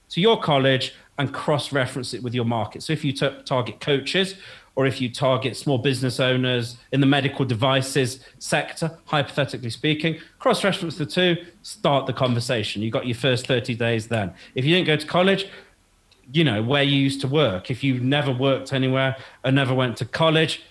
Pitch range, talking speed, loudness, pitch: 125-150 Hz, 195 wpm, -22 LUFS, 135 Hz